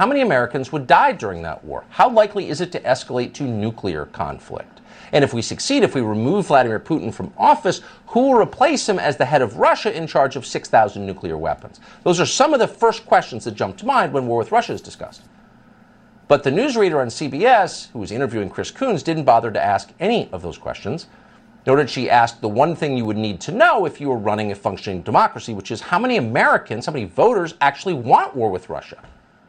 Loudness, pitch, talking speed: -19 LUFS, 135 Hz, 225 wpm